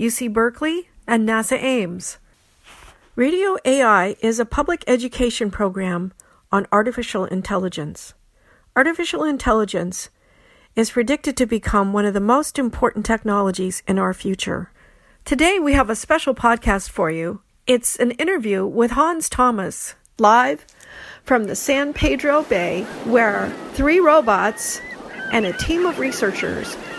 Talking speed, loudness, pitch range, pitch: 130 wpm, -19 LUFS, 200-280 Hz, 235 Hz